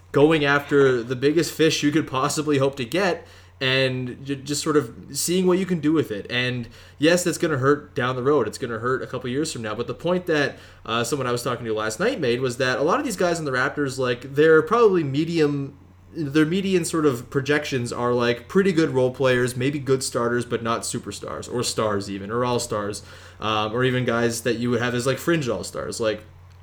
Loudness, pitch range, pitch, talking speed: -22 LUFS, 120-150 Hz, 130 Hz, 235 wpm